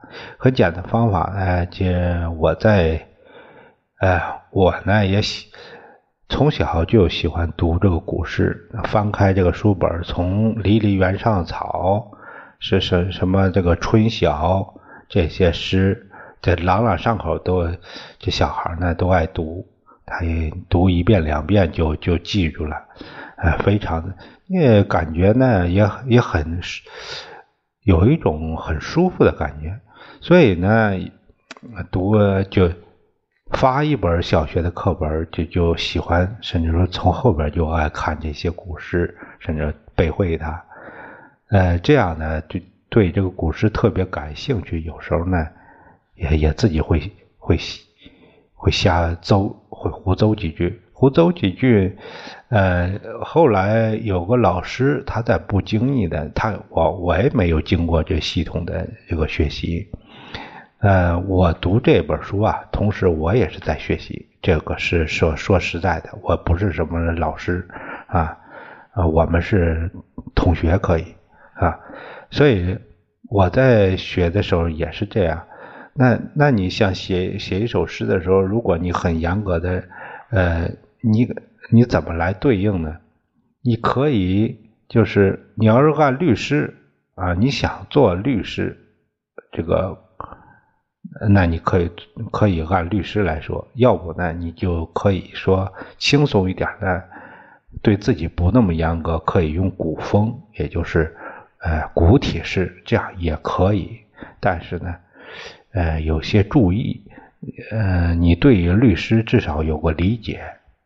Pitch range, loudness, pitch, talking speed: 85-105 Hz, -19 LUFS, 95 Hz, 195 characters per minute